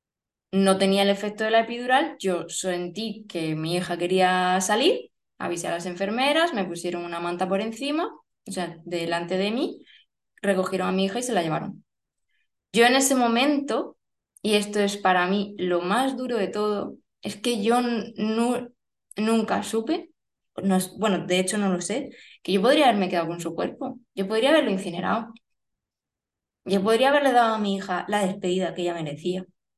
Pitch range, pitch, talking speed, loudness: 180-240 Hz, 200 Hz, 180 wpm, -24 LUFS